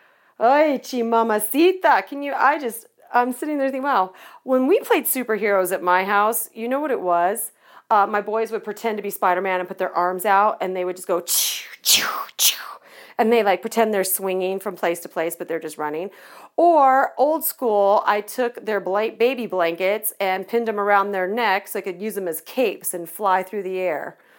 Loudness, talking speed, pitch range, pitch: -21 LUFS, 210 wpm, 185-235 Hz, 205 Hz